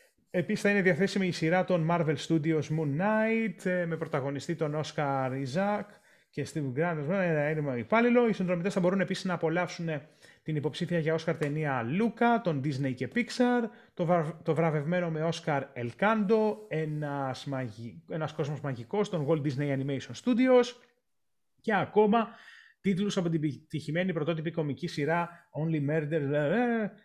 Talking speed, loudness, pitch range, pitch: 140 wpm, -30 LUFS, 150-200 Hz, 170 Hz